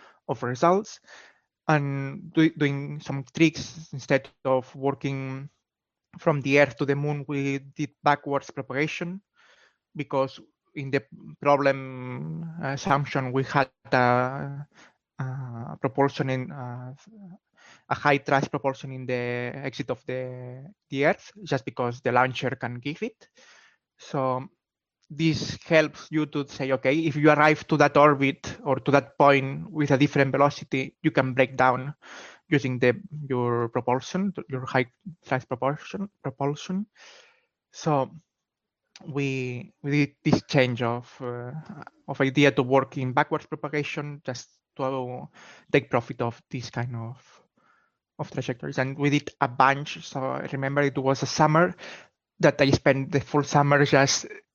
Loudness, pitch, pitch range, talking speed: -25 LUFS, 140 Hz, 130-150 Hz, 140 wpm